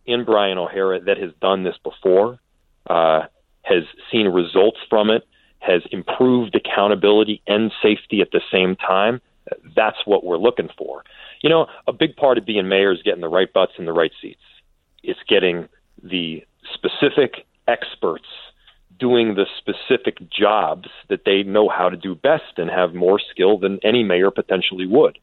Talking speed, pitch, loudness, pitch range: 165 wpm, 95 Hz, -19 LUFS, 90-110 Hz